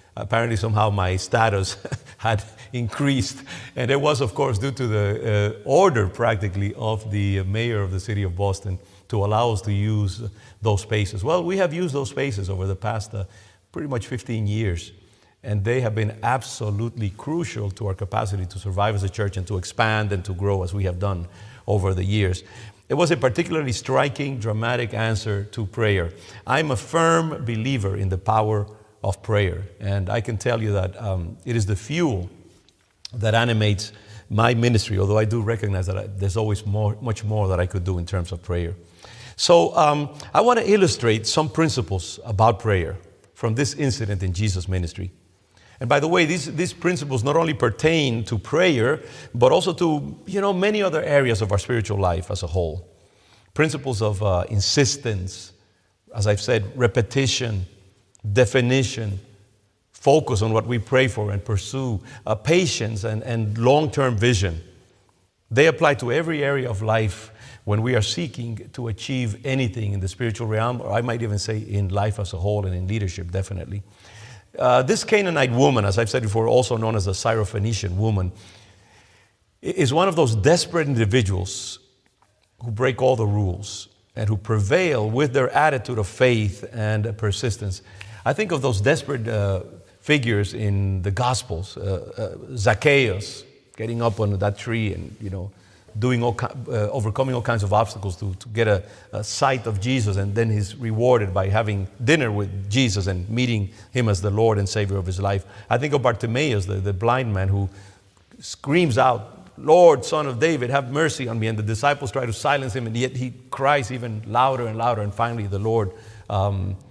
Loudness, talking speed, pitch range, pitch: -22 LUFS, 180 wpm, 100-125 Hz, 110 Hz